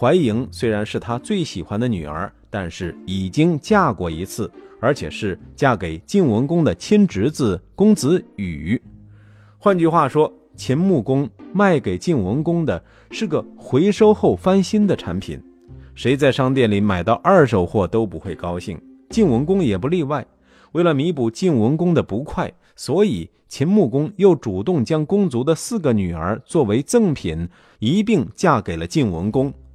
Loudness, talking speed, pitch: -19 LUFS, 240 characters per minute, 125 Hz